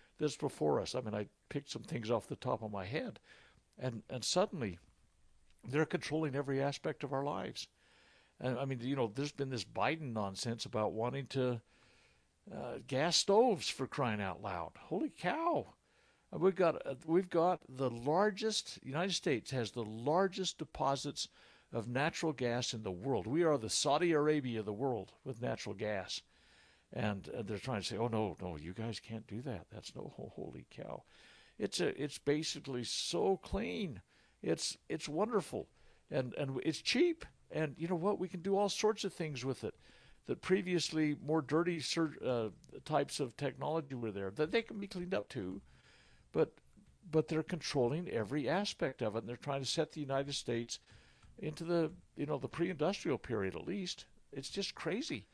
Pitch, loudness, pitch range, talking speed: 140 Hz, -37 LUFS, 115-165 Hz, 180 wpm